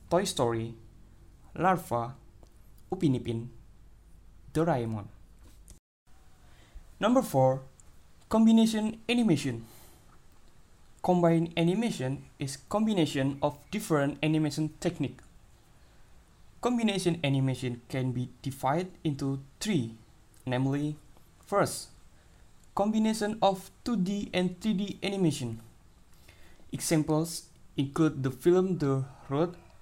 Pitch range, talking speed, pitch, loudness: 115-175 Hz, 85 wpm, 140 Hz, -30 LUFS